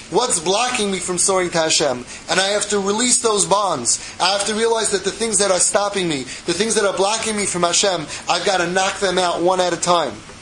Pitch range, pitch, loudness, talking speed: 175-205 Hz, 190 Hz, -17 LUFS, 240 wpm